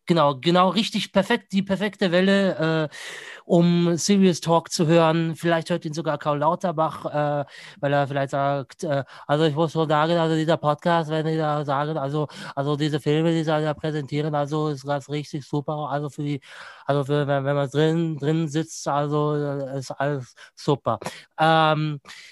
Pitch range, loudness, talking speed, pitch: 145-170 Hz, -23 LUFS, 175 wpm, 155 Hz